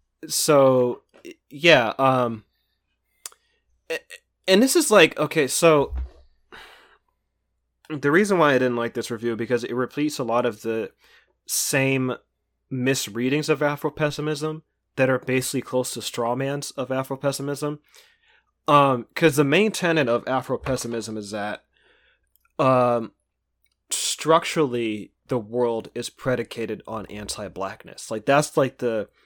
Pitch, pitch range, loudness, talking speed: 130 Hz, 115-150 Hz, -22 LUFS, 125 wpm